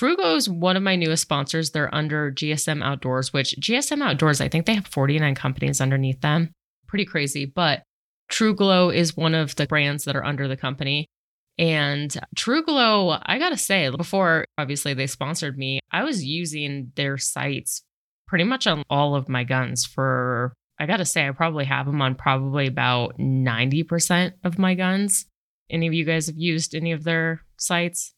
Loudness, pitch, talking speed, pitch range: -22 LUFS, 155 Hz, 175 wpm, 140-175 Hz